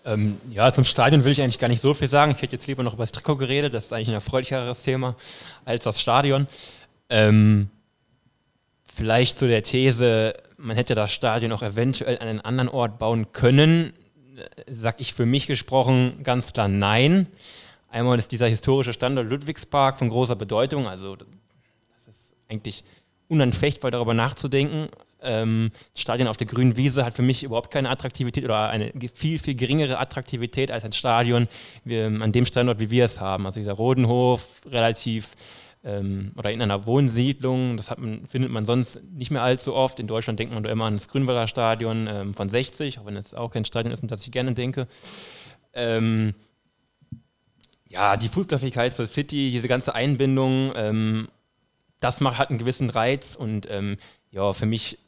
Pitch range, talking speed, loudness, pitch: 110-130 Hz, 180 wpm, -23 LUFS, 120 Hz